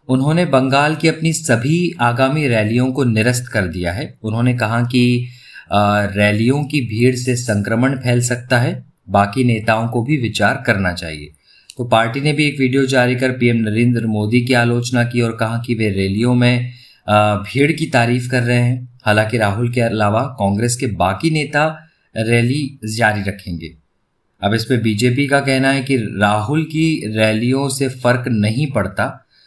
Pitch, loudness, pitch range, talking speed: 120 Hz, -16 LUFS, 110-130 Hz, 165 wpm